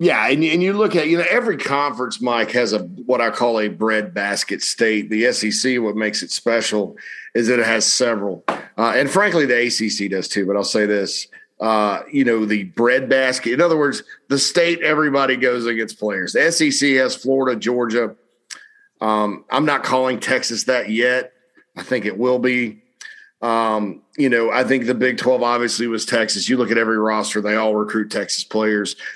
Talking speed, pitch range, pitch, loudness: 190 wpm, 110-135 Hz, 120 Hz, -18 LUFS